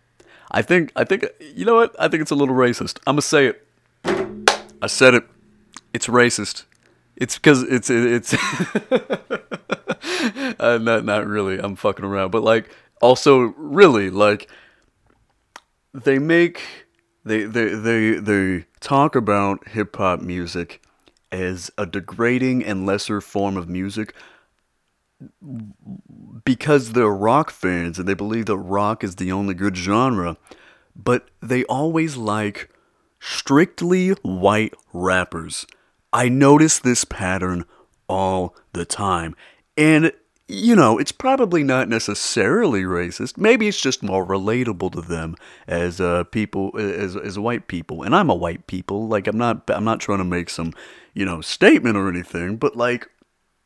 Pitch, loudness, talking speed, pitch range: 110 Hz, -19 LUFS, 145 wpm, 95-130 Hz